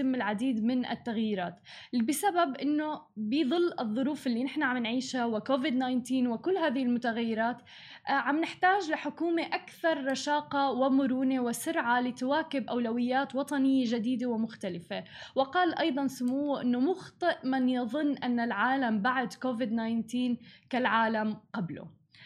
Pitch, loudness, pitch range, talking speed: 255 Hz, -30 LUFS, 235-285 Hz, 115 wpm